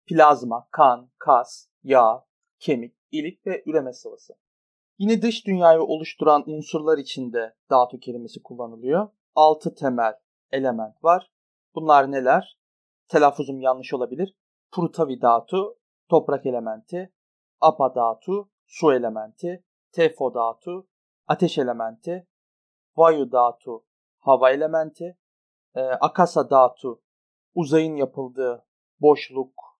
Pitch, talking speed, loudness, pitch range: 150 Hz, 95 wpm, -21 LUFS, 125-175 Hz